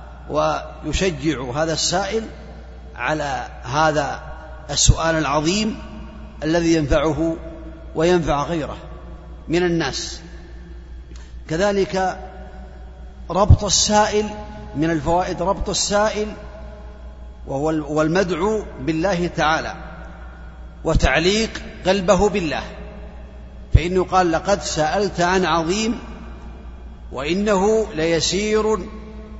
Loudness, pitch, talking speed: -20 LUFS, 160 Hz, 70 wpm